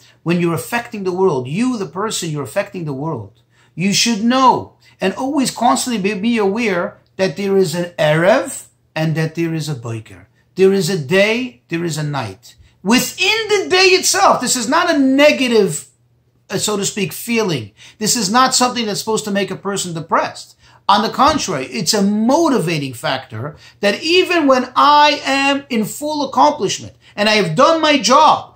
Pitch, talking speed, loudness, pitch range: 200 Hz, 180 wpm, -15 LUFS, 160-250 Hz